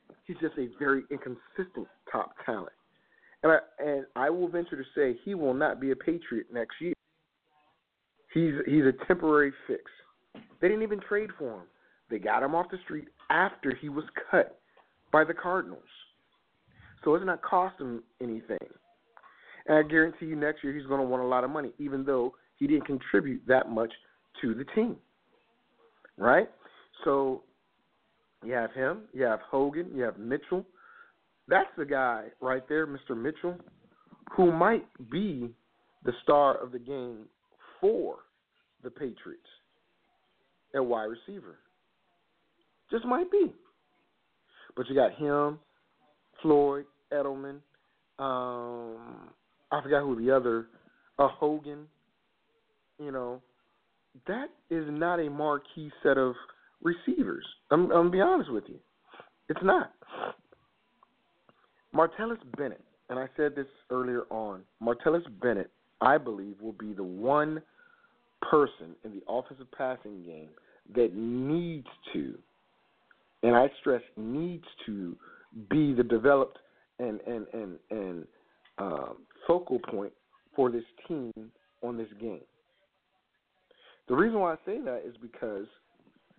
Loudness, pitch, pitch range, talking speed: -30 LUFS, 145 Hz, 125-170 Hz, 140 wpm